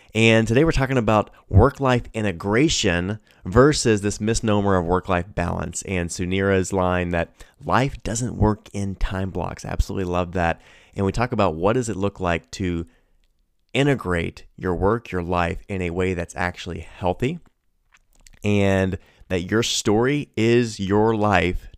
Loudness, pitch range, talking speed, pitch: -22 LUFS, 90-110 Hz, 155 wpm, 100 Hz